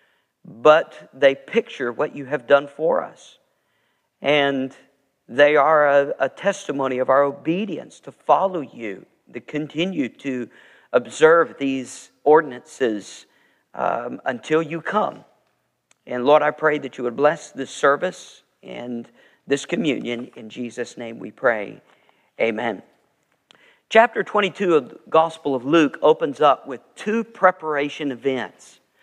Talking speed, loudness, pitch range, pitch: 130 wpm, -20 LUFS, 135-165 Hz, 145 Hz